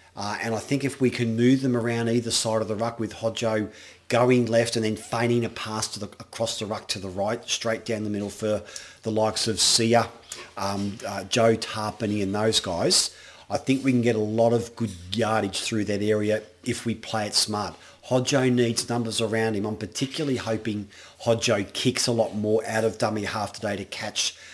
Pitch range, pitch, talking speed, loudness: 105-115 Hz, 110 Hz, 210 wpm, -25 LUFS